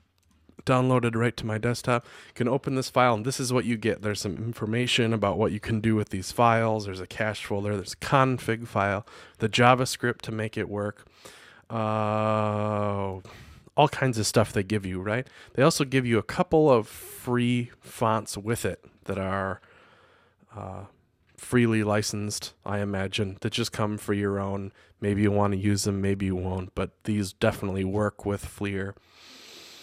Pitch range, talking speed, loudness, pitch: 100-120 Hz, 180 wpm, -26 LUFS, 110 Hz